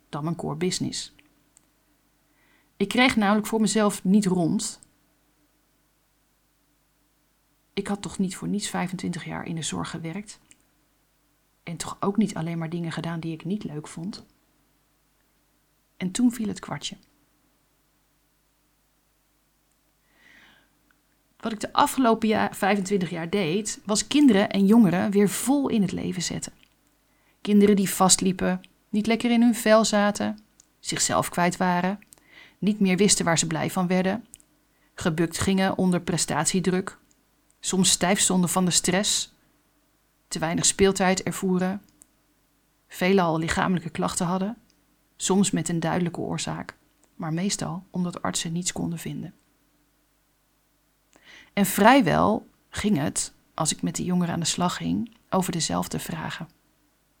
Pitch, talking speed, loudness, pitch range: 185 Hz, 130 wpm, -24 LUFS, 170-205 Hz